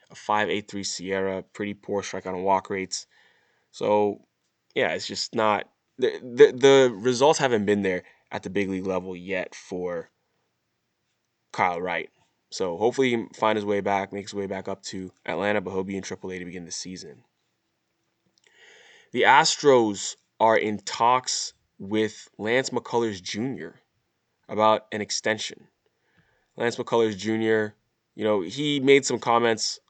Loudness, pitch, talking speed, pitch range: -25 LUFS, 105 Hz, 155 wpm, 95-115 Hz